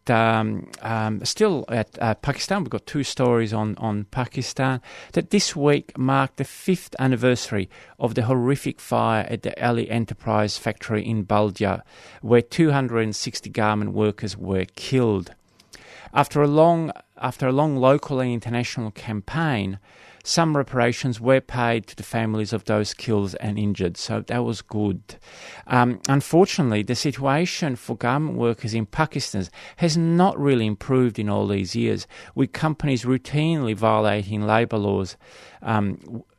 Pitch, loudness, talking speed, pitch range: 120 Hz, -23 LUFS, 150 wpm, 105-135 Hz